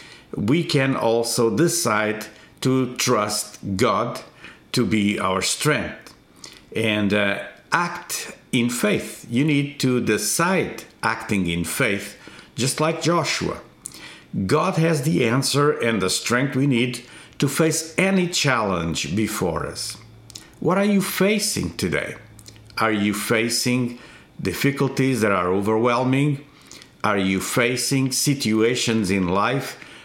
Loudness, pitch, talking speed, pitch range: -21 LUFS, 120 Hz, 120 wpm, 110-140 Hz